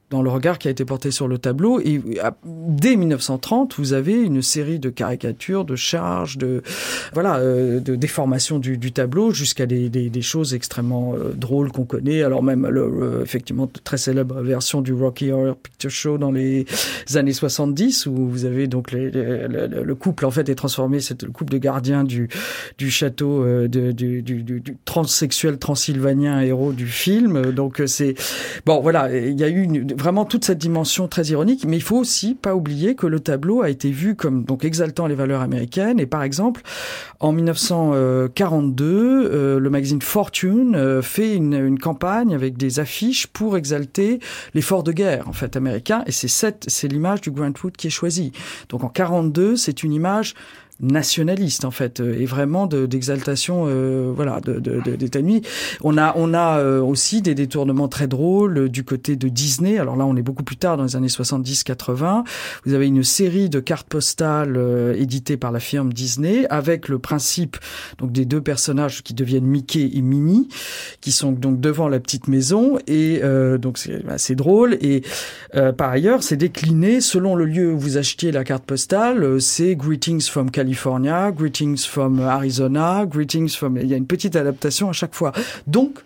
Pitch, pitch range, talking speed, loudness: 140 Hz, 130-170 Hz, 190 wpm, -19 LUFS